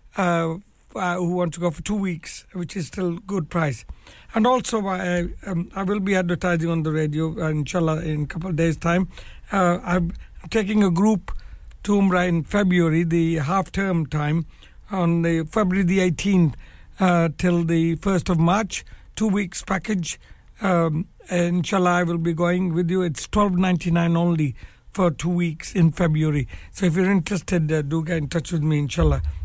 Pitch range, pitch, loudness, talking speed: 165-185 Hz, 175 Hz, -22 LUFS, 175 wpm